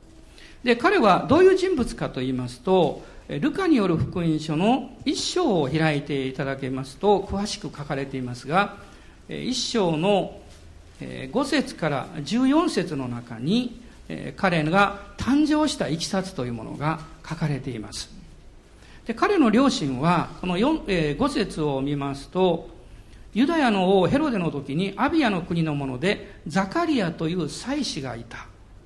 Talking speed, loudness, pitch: 270 characters per minute, -24 LUFS, 175 Hz